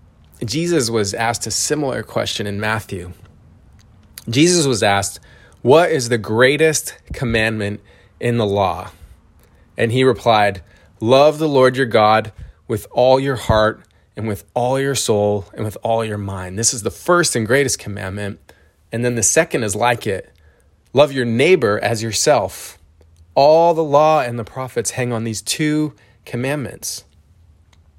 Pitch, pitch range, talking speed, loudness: 110 Hz, 100-130 Hz, 150 wpm, -17 LUFS